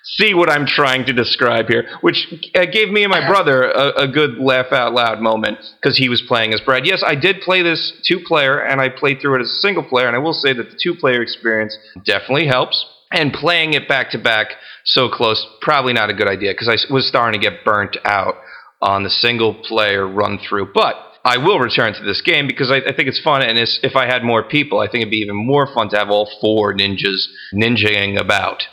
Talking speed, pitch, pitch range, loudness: 240 wpm, 125 Hz, 110-150 Hz, -15 LUFS